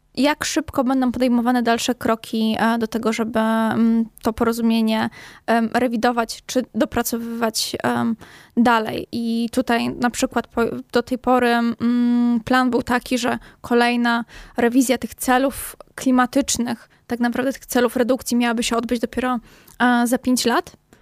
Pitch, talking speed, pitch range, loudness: 240 Hz, 125 wpm, 230-250 Hz, -20 LUFS